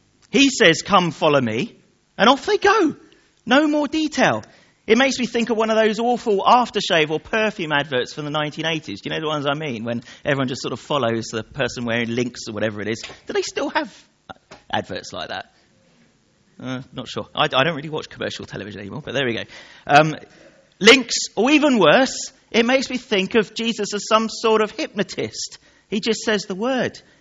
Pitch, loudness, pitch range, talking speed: 210 Hz, -19 LUFS, 145-245 Hz, 205 wpm